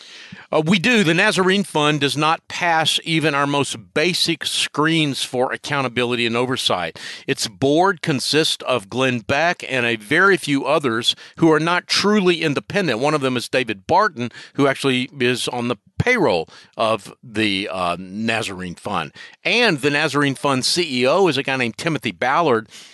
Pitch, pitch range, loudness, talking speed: 140 Hz, 125-165 Hz, -19 LUFS, 160 wpm